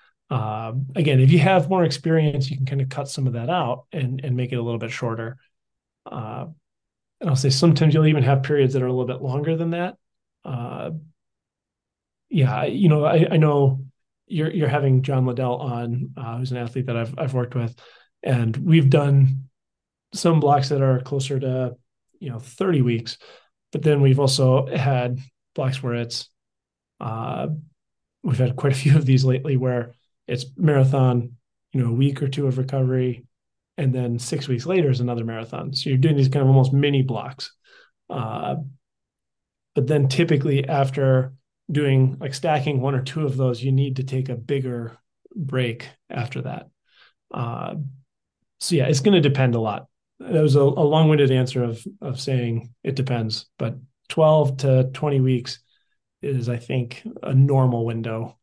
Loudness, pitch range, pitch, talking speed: -21 LUFS, 125-145 Hz, 135 Hz, 180 wpm